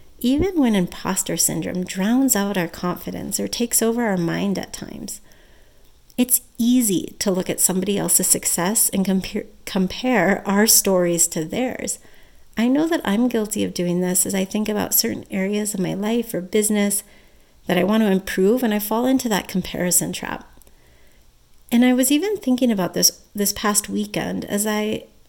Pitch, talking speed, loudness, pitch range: 205 Hz, 175 wpm, -20 LUFS, 180-235 Hz